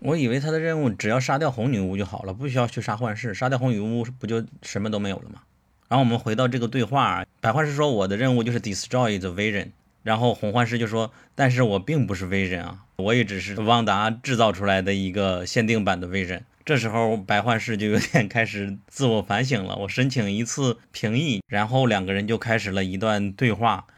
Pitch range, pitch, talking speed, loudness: 100-125 Hz, 115 Hz, 385 characters per minute, -24 LUFS